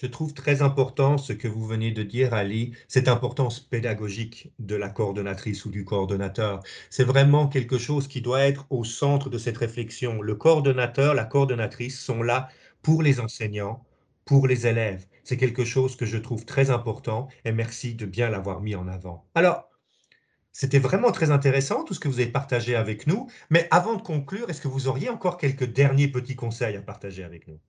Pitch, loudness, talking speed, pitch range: 125 Hz, -25 LUFS, 195 wpm, 110-140 Hz